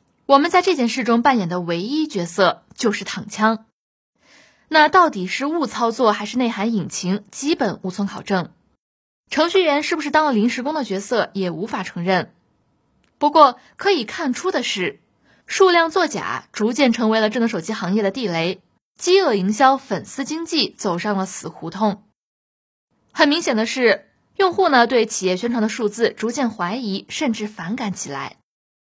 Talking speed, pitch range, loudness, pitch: 255 characters per minute, 200-290 Hz, -19 LUFS, 225 Hz